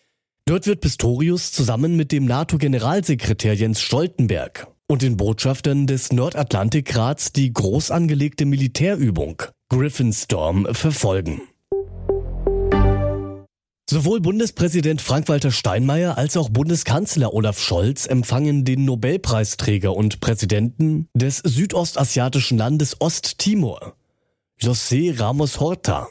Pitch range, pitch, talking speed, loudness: 115-155 Hz, 135 Hz, 95 wpm, -19 LUFS